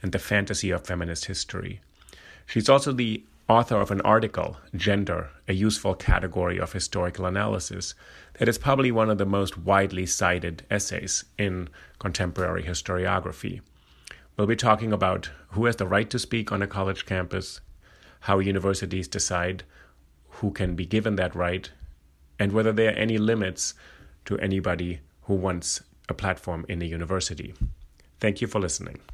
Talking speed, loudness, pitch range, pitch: 155 wpm, -26 LUFS, 90-105 Hz, 95 Hz